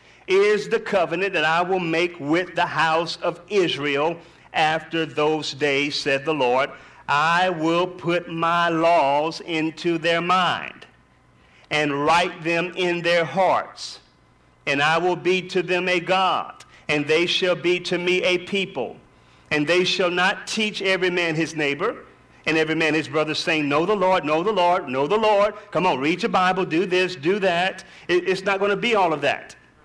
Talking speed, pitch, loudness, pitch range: 180 wpm, 175 Hz, -21 LUFS, 160-185 Hz